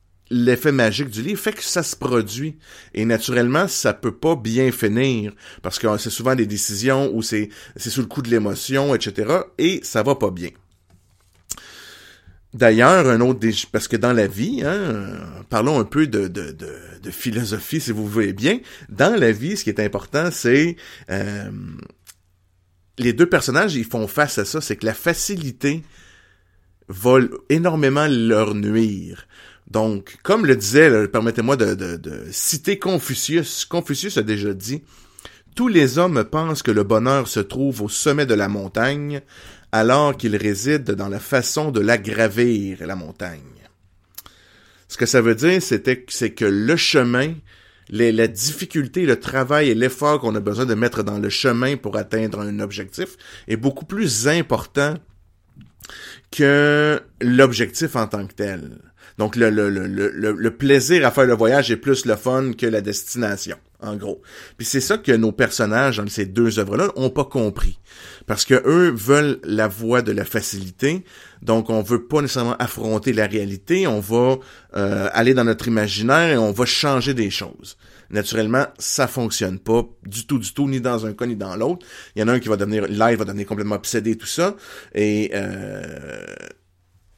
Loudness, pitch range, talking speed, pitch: -19 LUFS, 105-135 Hz, 180 wpm, 115 Hz